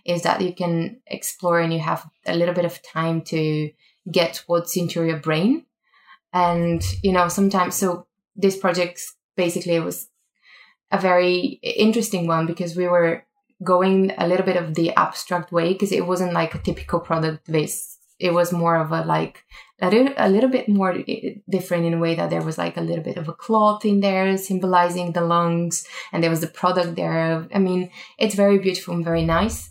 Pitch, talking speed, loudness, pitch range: 175 Hz, 195 wpm, -21 LUFS, 165-190 Hz